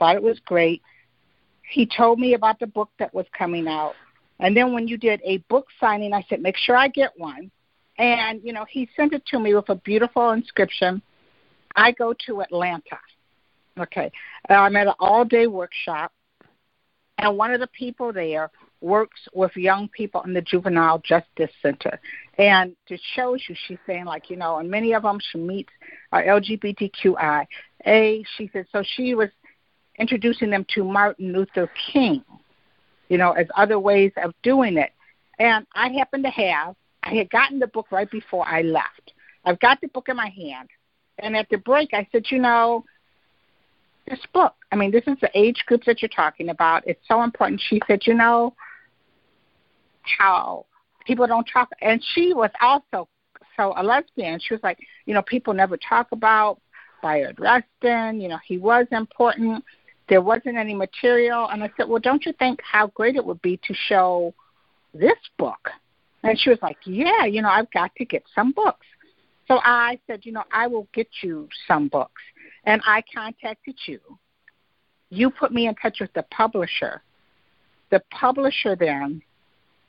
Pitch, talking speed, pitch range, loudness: 220 Hz, 180 wpm, 190-240 Hz, -21 LUFS